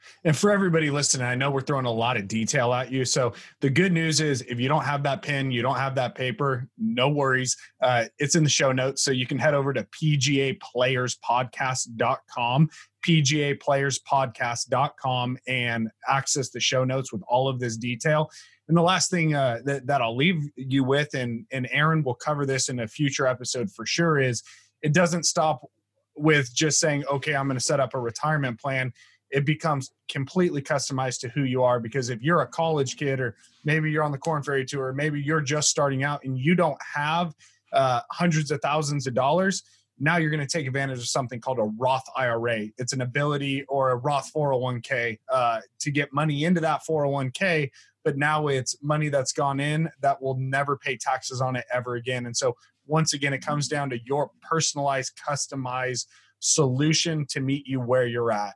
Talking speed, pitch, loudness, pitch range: 195 wpm, 140 Hz, -25 LUFS, 125-150 Hz